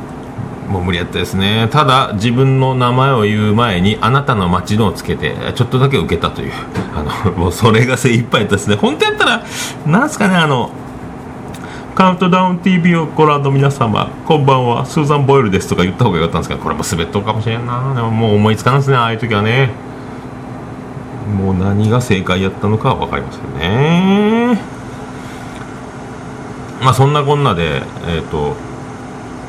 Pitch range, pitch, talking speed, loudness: 105-135 Hz, 120 Hz, 370 characters per minute, -14 LUFS